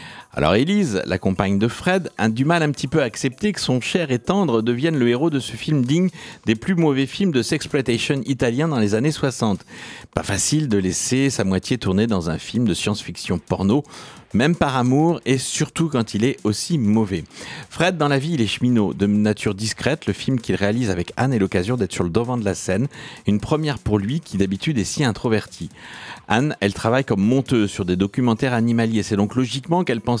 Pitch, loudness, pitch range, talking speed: 125 Hz, -20 LUFS, 105-150 Hz, 215 wpm